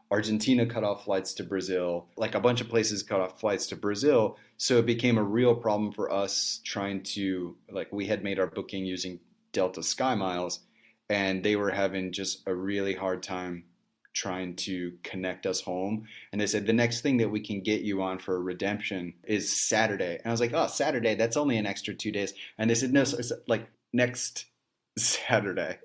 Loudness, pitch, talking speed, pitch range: -29 LUFS, 100 Hz, 205 wpm, 95-115 Hz